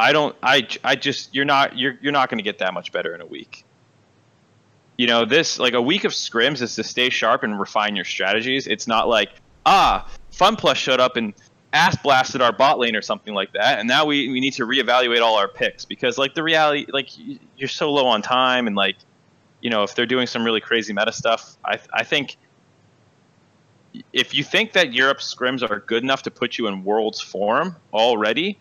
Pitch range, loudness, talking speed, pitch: 115-140 Hz, -19 LUFS, 215 wpm, 130 Hz